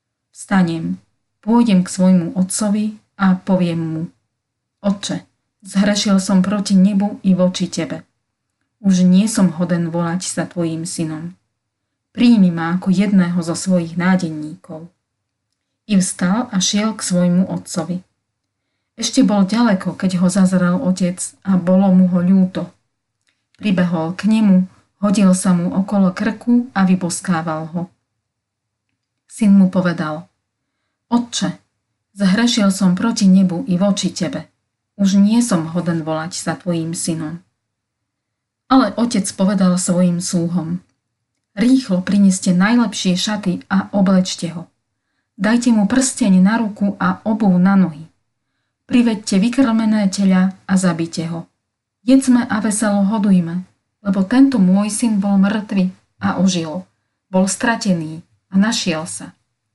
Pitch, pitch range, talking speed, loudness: 185 Hz, 165-200 Hz, 125 wpm, -16 LUFS